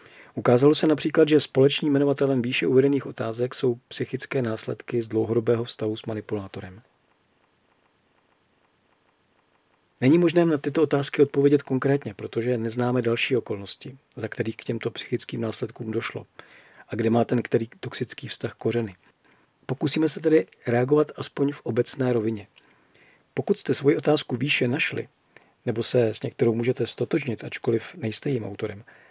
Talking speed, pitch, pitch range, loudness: 140 wpm, 125 Hz, 115-140 Hz, -24 LUFS